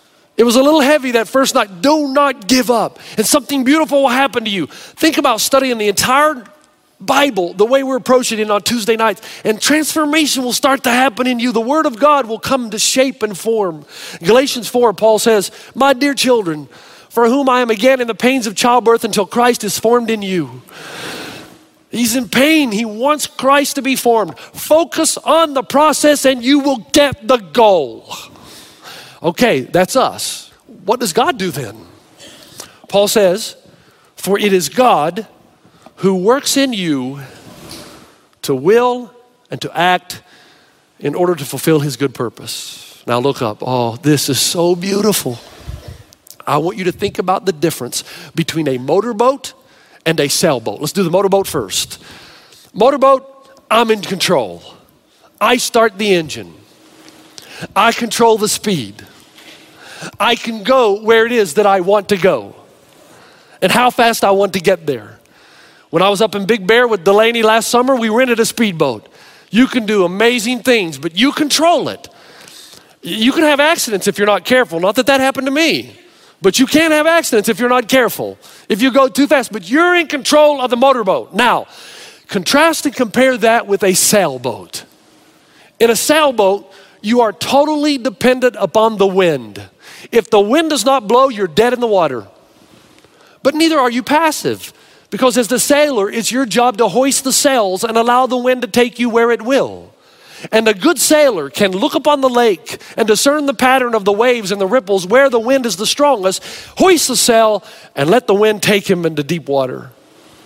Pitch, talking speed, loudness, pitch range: 235 Hz, 180 wpm, -13 LUFS, 195-270 Hz